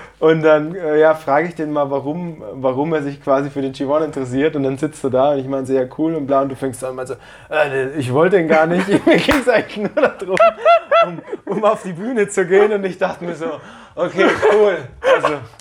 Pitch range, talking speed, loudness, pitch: 135-190 Hz, 240 wpm, -17 LUFS, 155 Hz